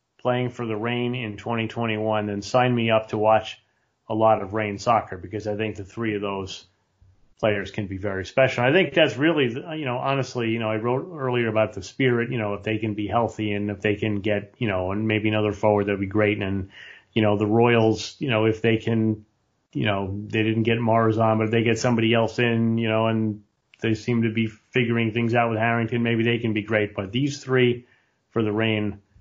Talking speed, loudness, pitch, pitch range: 230 wpm, -23 LUFS, 110 Hz, 105-120 Hz